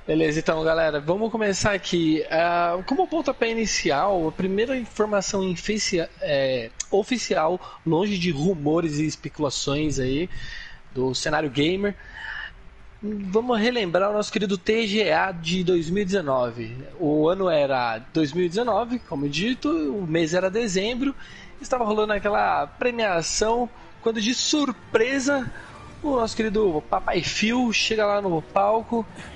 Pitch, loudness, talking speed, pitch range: 200 Hz, -23 LUFS, 120 wpm, 160-230 Hz